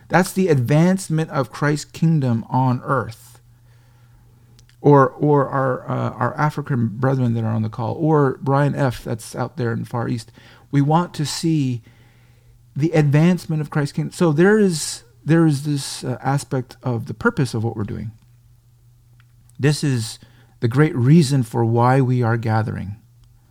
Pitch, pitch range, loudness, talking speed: 125 Hz, 120-145 Hz, -19 LUFS, 165 wpm